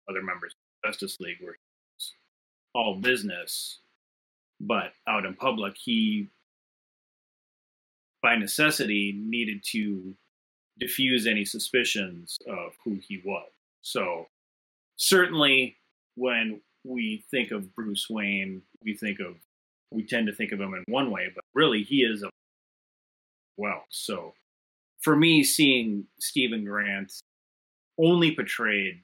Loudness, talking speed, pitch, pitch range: -26 LUFS, 120 wpm, 110 Hz, 100-135 Hz